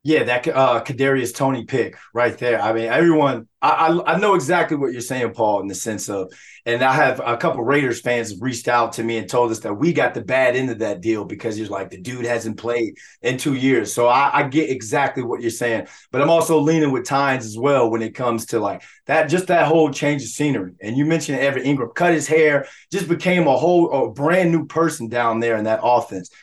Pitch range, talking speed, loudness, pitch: 115-155 Hz, 240 wpm, -19 LUFS, 130 Hz